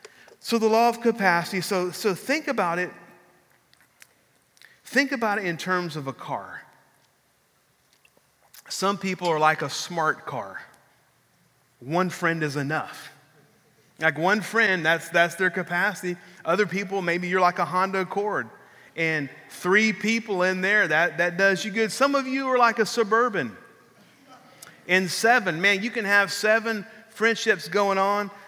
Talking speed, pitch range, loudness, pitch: 150 wpm, 175-220 Hz, -23 LUFS, 190 Hz